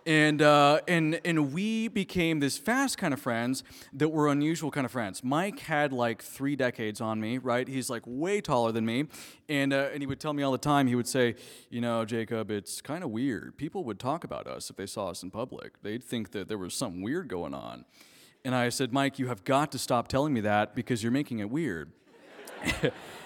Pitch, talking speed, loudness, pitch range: 130 Hz, 225 wpm, -29 LUFS, 120-150 Hz